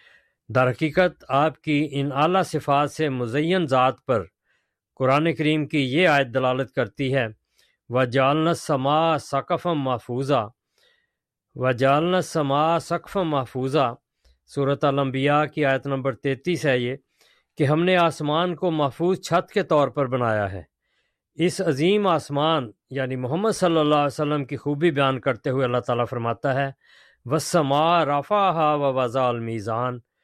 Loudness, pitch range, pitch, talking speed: -22 LUFS, 130-160 Hz, 145 Hz, 140 wpm